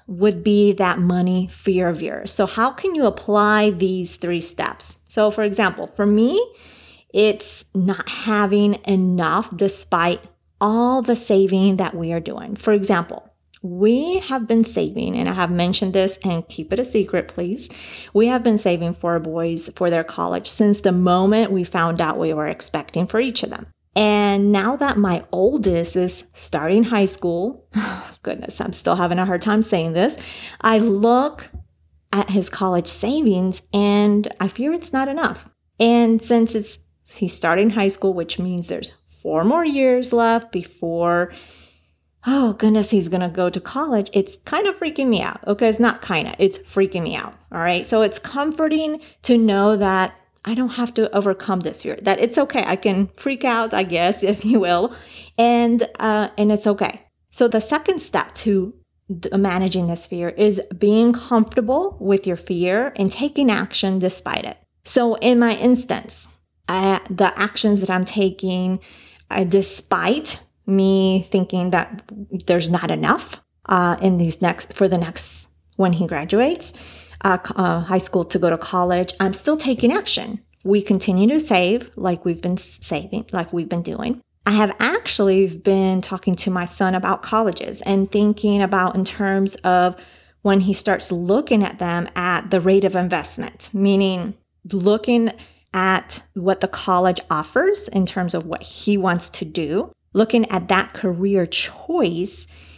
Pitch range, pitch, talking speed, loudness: 180-220 Hz, 195 Hz, 170 wpm, -19 LUFS